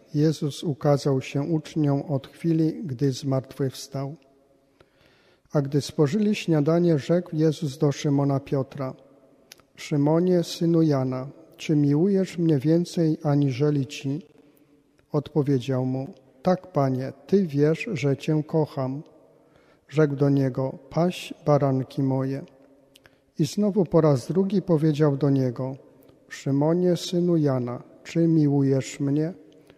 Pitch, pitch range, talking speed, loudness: 145 Hz, 135-160 Hz, 110 wpm, -24 LUFS